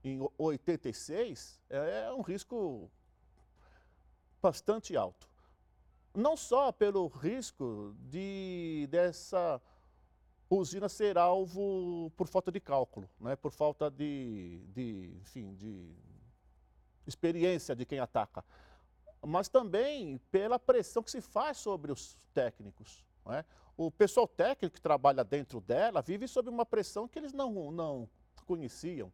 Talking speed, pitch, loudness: 120 wpm, 165 Hz, -35 LUFS